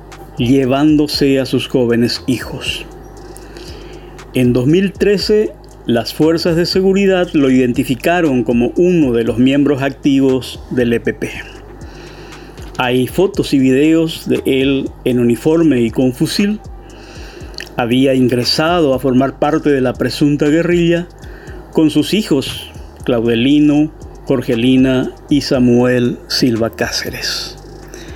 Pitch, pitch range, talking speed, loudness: 135 Hz, 125-160 Hz, 105 wpm, -14 LUFS